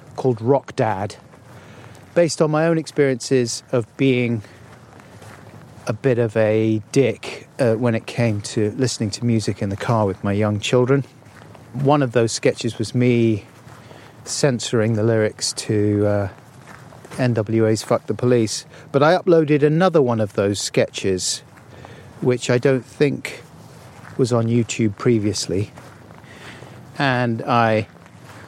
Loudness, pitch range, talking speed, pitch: -20 LUFS, 110-135 Hz, 135 wpm, 120 Hz